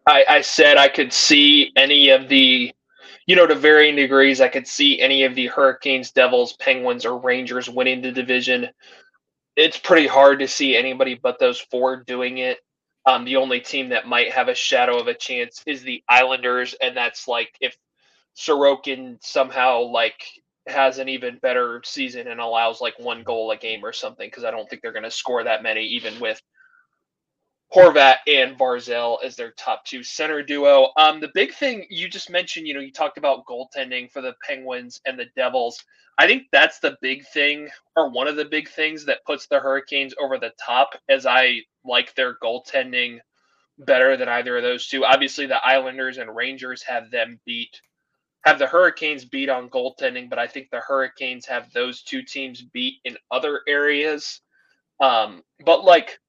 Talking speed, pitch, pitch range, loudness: 185 wpm, 135 Hz, 125-180 Hz, -18 LUFS